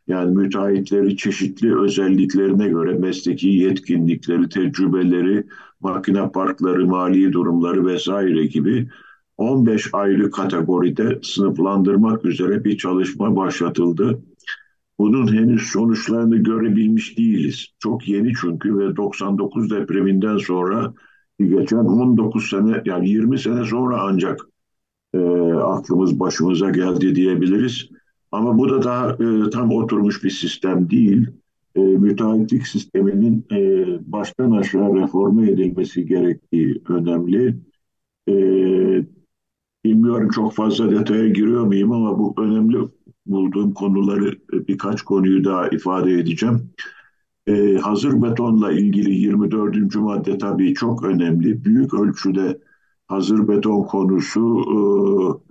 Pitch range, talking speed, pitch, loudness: 95-110 Hz, 105 wpm, 100 Hz, -18 LUFS